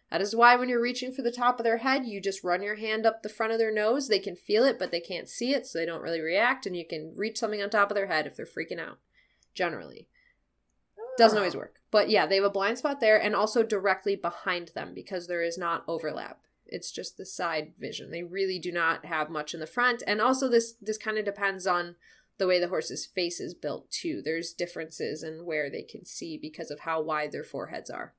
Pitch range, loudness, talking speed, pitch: 170-225 Hz, -28 LUFS, 250 wpm, 200 Hz